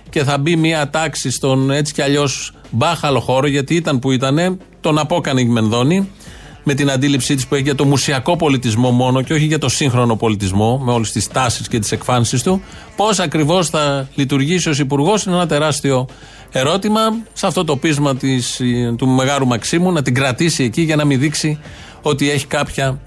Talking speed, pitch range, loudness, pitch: 190 wpm, 130-155 Hz, -16 LUFS, 140 Hz